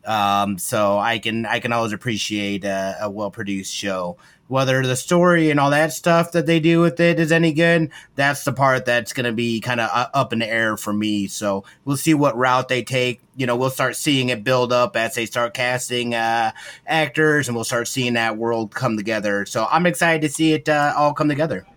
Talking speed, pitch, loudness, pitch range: 225 wpm, 125 Hz, -19 LUFS, 110-145 Hz